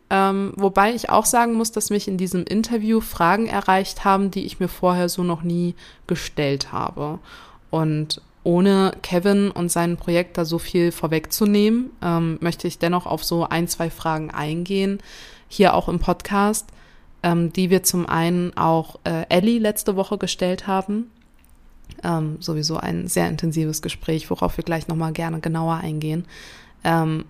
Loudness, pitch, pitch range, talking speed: -21 LUFS, 175 Hz, 165-195 Hz, 160 wpm